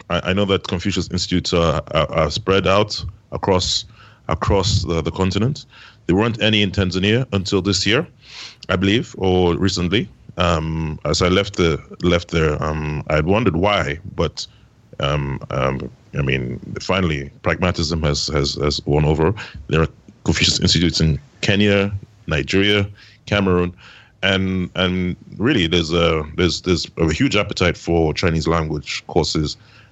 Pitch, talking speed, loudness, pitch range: 90 Hz, 145 wpm, -19 LUFS, 80-100 Hz